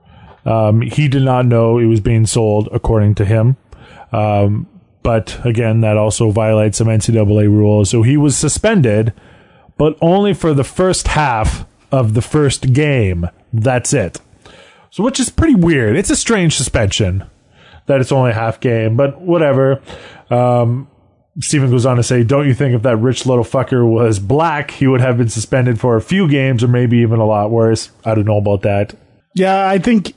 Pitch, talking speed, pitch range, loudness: 120 Hz, 185 wpm, 110-140 Hz, -14 LUFS